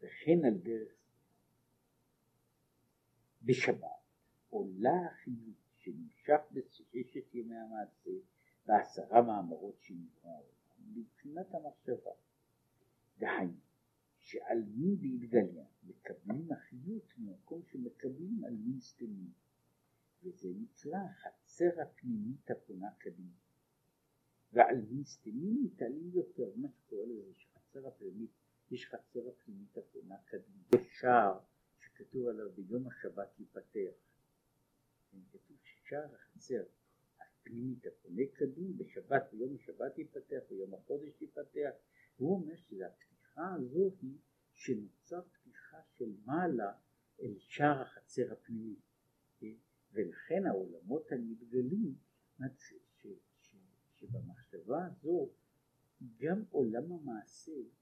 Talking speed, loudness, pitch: 90 wpm, -38 LUFS, 145 Hz